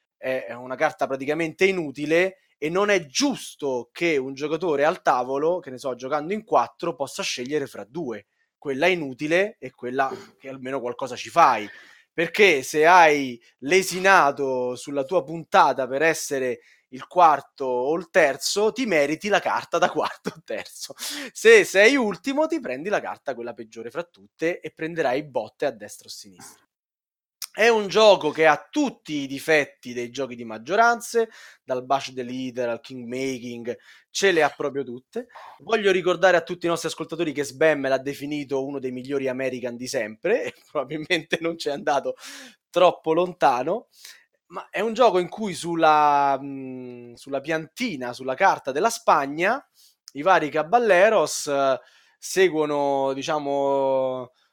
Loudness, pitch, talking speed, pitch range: -22 LUFS, 150 Hz, 155 wpm, 130-185 Hz